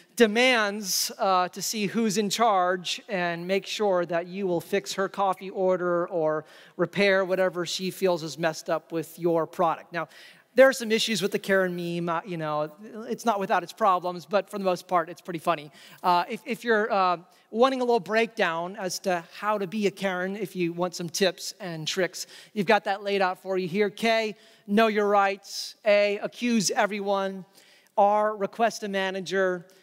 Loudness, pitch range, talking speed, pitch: -26 LUFS, 180-210 Hz, 190 wpm, 195 Hz